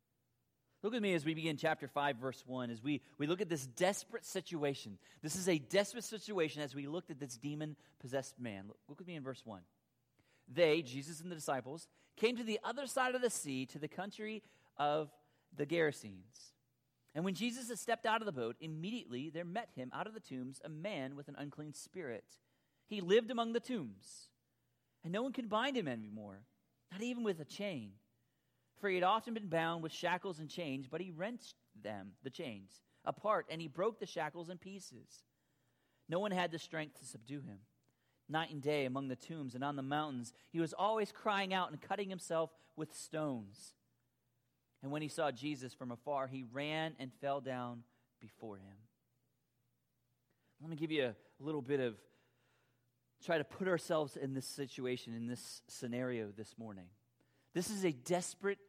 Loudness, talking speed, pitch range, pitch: -40 LUFS, 190 wpm, 130-180 Hz, 150 Hz